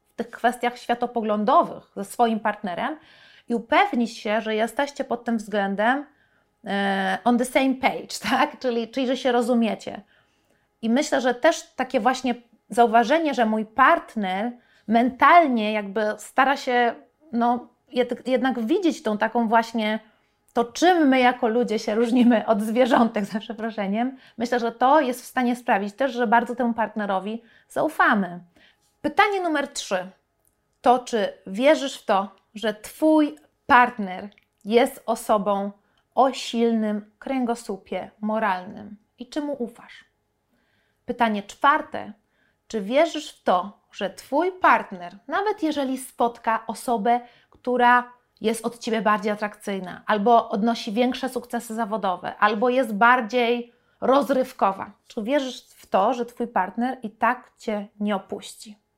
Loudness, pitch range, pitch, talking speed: -23 LUFS, 215-260 Hz, 235 Hz, 130 wpm